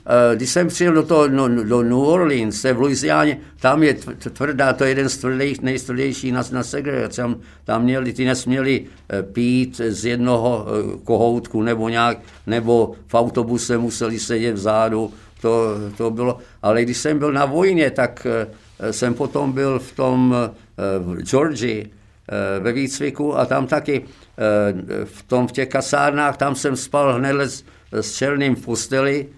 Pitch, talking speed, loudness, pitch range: 125 Hz, 155 wpm, -19 LUFS, 115-135 Hz